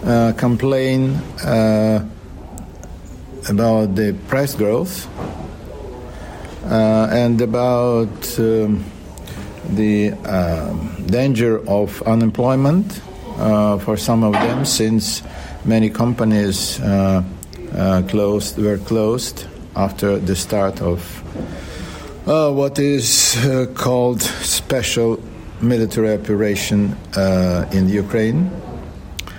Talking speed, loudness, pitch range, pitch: 90 wpm, -17 LUFS, 95-115 Hz, 105 Hz